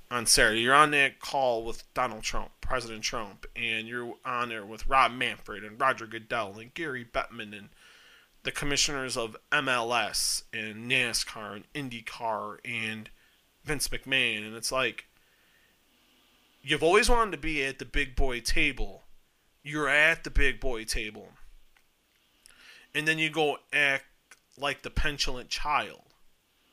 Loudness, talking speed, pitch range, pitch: -28 LUFS, 145 wpm, 115-145 Hz, 130 Hz